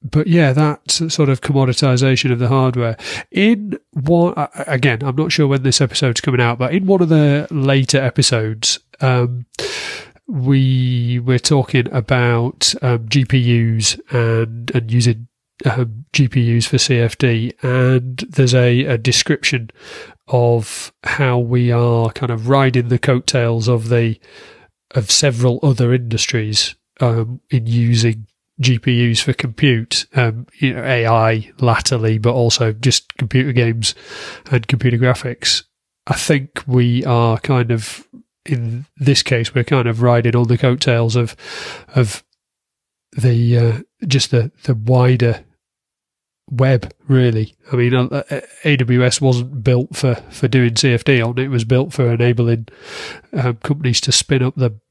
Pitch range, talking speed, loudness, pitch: 120-135 Hz, 140 wpm, -16 LUFS, 125 Hz